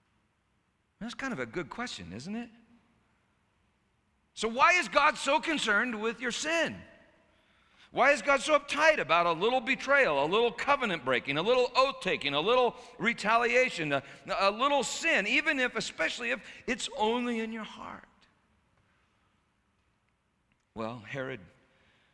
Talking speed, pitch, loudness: 140 wpm, 230 Hz, -28 LUFS